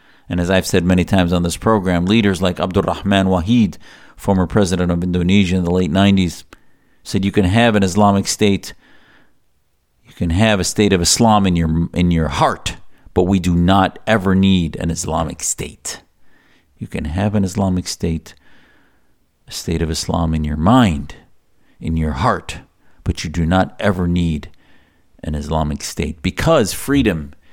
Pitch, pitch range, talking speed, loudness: 90 Hz, 85-100 Hz, 165 wpm, -17 LUFS